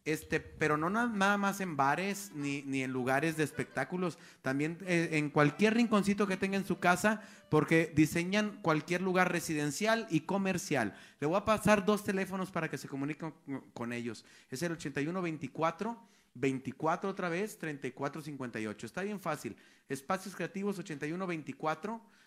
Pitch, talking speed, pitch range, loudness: 165 Hz, 145 wpm, 145-195 Hz, -33 LUFS